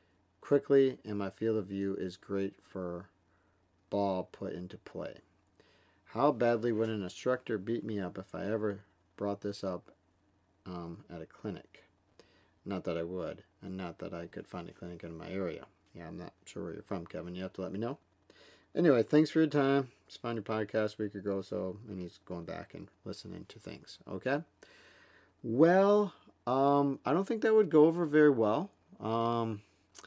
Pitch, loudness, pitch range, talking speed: 100 Hz, -33 LUFS, 95-125 Hz, 190 wpm